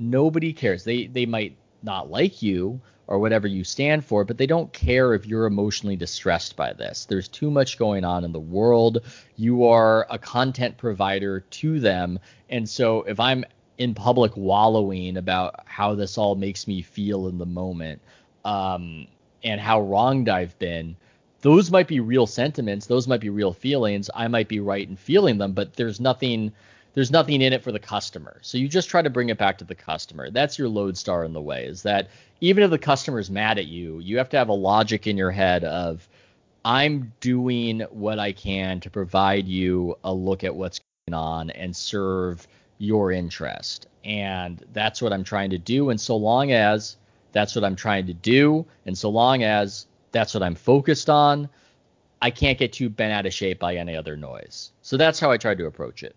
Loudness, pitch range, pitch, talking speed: -23 LUFS, 95-125 Hz, 105 Hz, 200 wpm